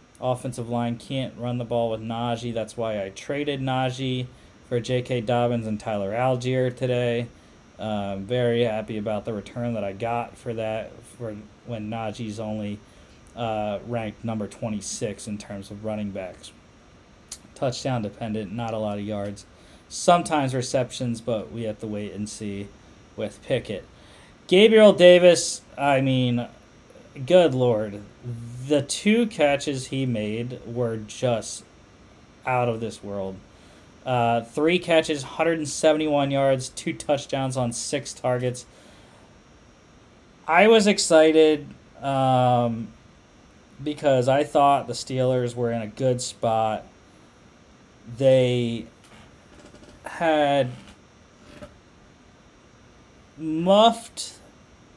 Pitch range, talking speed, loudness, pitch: 110-135 Hz, 115 wpm, -23 LUFS, 120 Hz